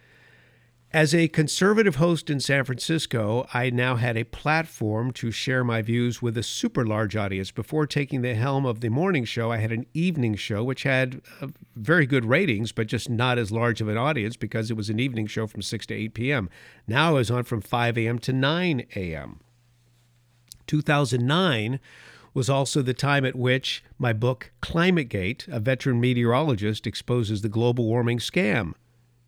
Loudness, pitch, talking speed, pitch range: -24 LUFS, 120 Hz, 175 wpm, 115-135 Hz